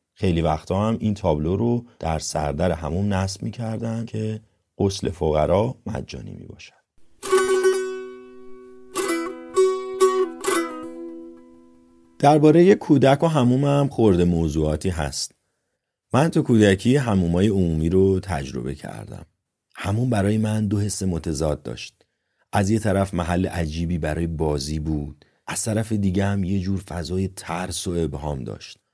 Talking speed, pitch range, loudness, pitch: 125 wpm, 85-120 Hz, -22 LUFS, 95 Hz